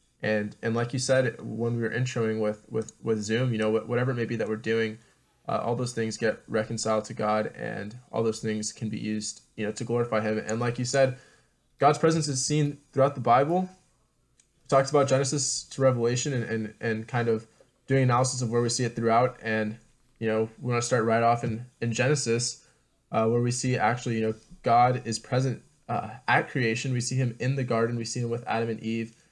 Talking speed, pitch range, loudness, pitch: 225 wpm, 110-130 Hz, -27 LUFS, 115 Hz